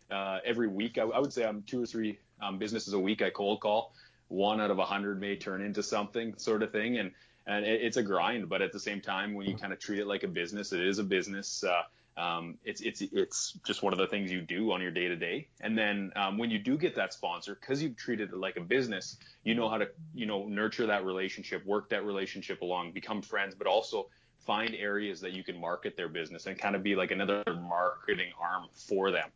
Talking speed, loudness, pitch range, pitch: 250 wpm, -33 LUFS, 95-110 Hz, 100 Hz